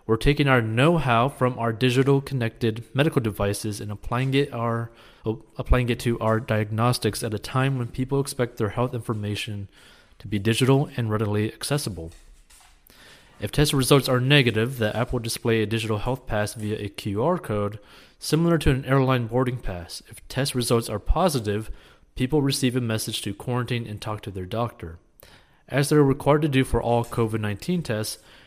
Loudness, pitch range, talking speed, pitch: -24 LUFS, 110-130 Hz, 175 wpm, 115 Hz